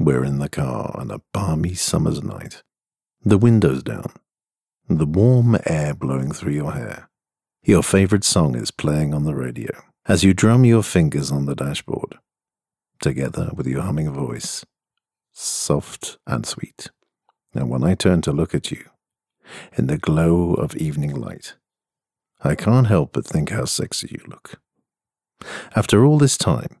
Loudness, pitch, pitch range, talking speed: -20 LUFS, 85 Hz, 75-105 Hz, 160 wpm